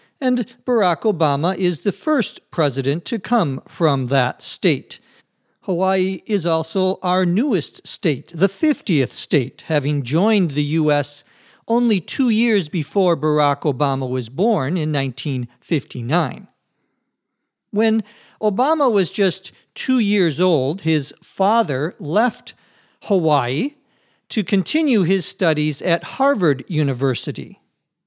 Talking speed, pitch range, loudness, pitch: 115 wpm, 150-215 Hz, -19 LUFS, 180 Hz